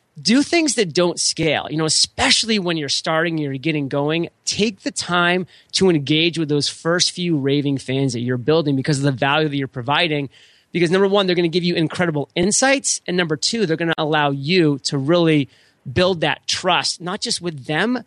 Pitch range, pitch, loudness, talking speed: 145-180 Hz, 160 Hz, -18 LUFS, 205 wpm